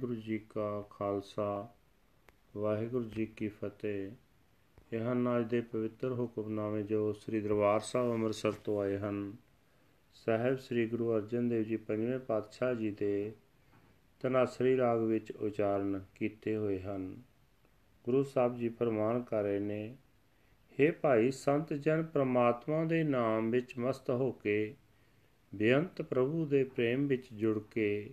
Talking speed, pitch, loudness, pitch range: 135 wpm, 110 Hz, -34 LUFS, 105-125 Hz